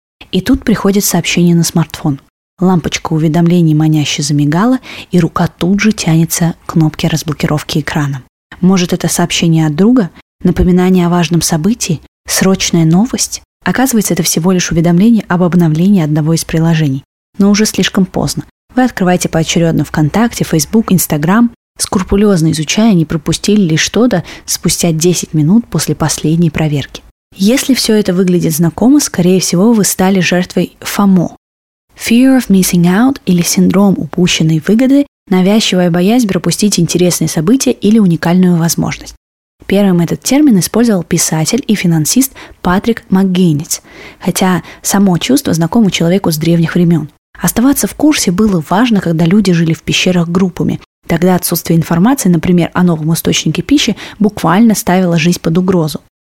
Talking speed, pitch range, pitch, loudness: 140 wpm, 165-205 Hz, 180 Hz, -11 LUFS